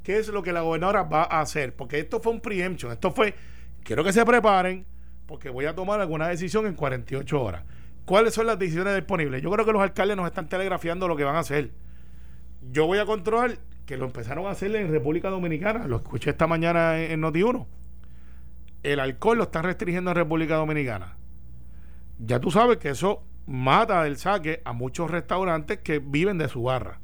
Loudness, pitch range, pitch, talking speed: -25 LUFS, 130-190 Hz, 160 Hz, 195 wpm